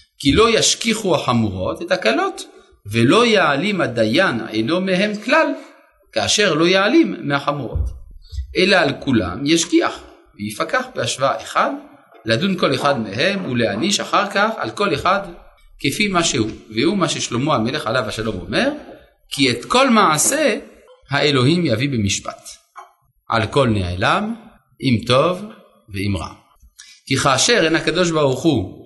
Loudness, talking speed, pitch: -17 LUFS, 130 wpm, 145 Hz